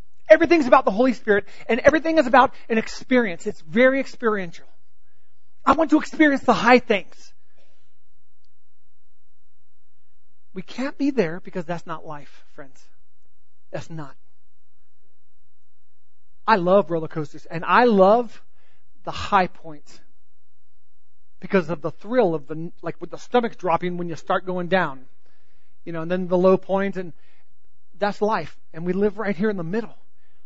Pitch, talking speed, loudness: 165 Hz, 150 wpm, -21 LUFS